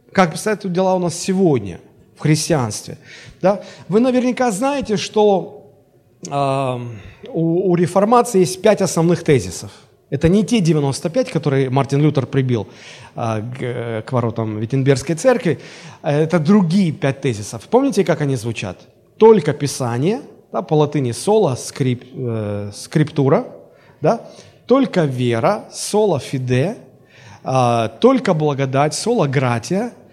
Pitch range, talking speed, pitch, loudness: 130-190 Hz, 115 wpm, 150 Hz, -17 LUFS